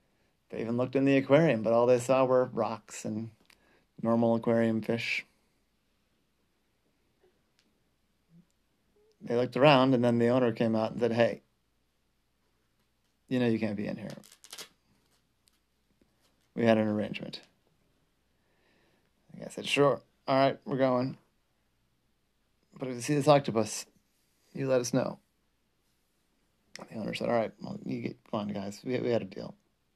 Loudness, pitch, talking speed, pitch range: -29 LUFS, 120 Hz, 140 wpm, 115-130 Hz